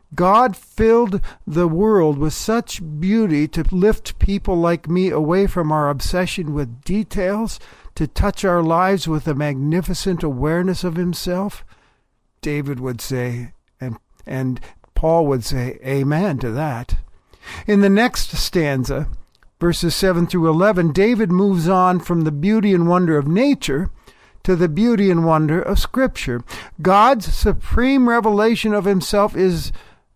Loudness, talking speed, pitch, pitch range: -18 LUFS, 140 wpm, 175 Hz, 150-200 Hz